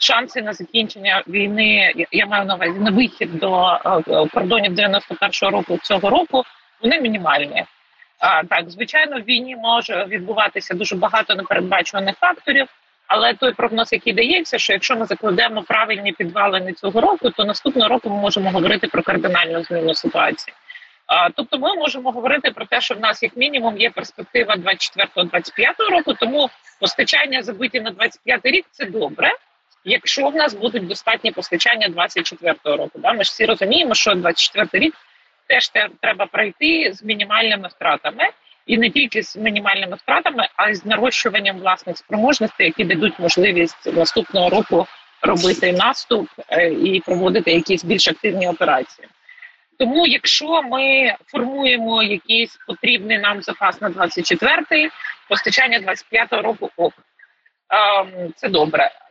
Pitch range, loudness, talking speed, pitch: 190-250 Hz, -17 LUFS, 140 wpm, 220 Hz